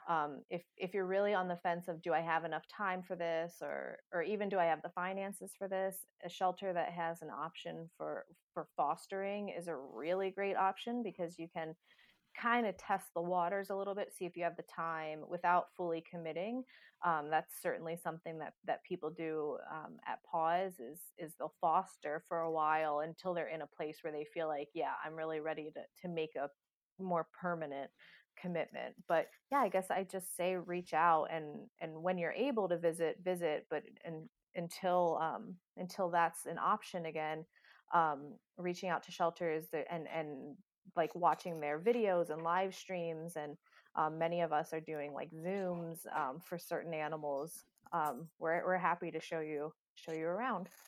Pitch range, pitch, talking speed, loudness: 160-185 Hz, 170 Hz, 190 wpm, -39 LUFS